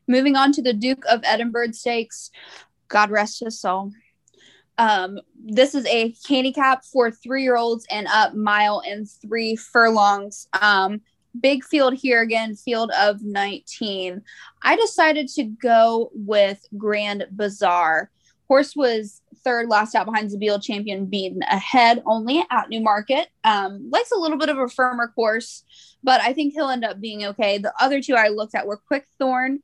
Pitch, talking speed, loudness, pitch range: 230 Hz, 160 wpm, -20 LUFS, 210-260 Hz